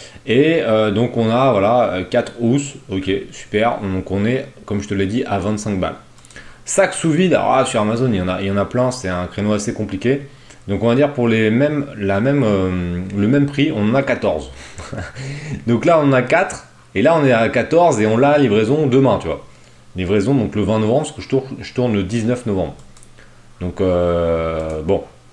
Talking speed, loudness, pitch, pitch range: 225 wpm, -17 LUFS, 110 Hz, 100-135 Hz